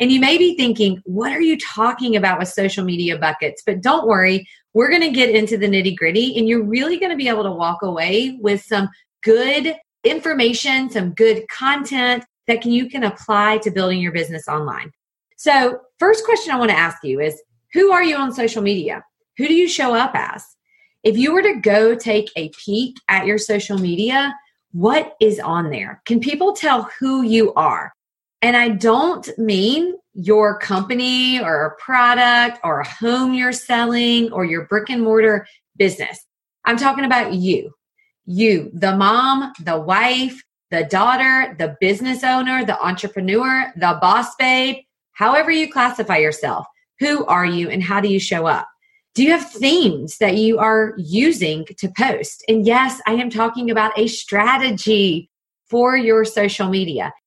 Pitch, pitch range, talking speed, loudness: 225 Hz, 195-260 Hz, 175 wpm, -17 LUFS